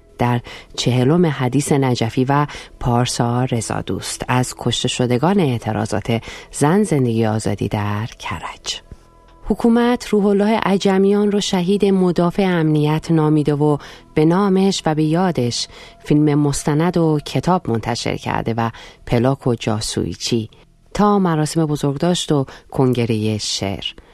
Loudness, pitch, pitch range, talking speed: -18 LUFS, 140 Hz, 120-170 Hz, 120 wpm